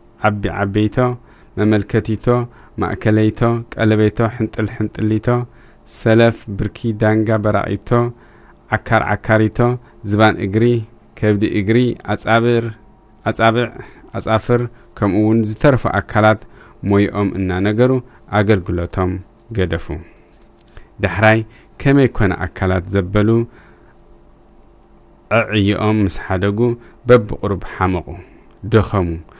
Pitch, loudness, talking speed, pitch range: 110 Hz, -17 LUFS, 80 wpm, 100-115 Hz